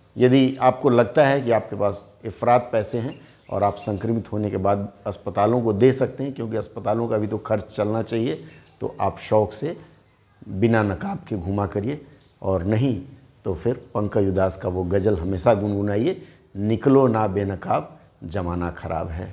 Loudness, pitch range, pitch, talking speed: -22 LUFS, 100-120 Hz, 110 Hz, 170 wpm